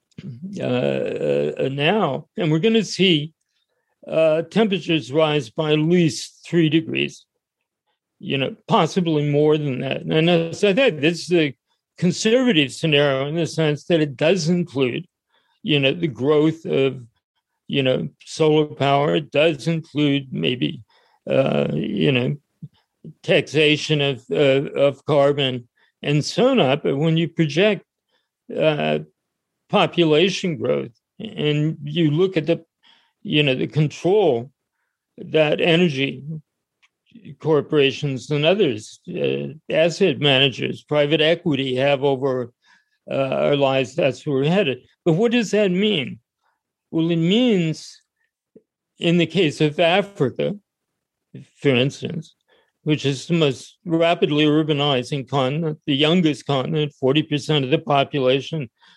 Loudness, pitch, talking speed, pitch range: -20 LUFS, 155 Hz, 130 wpm, 140-170 Hz